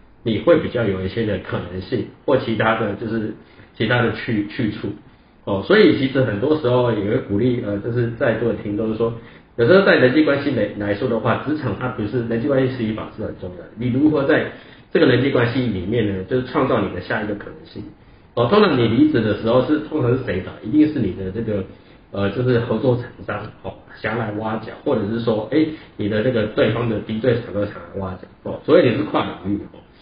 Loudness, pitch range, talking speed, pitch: -20 LUFS, 105-125 Hz, 330 characters per minute, 115 Hz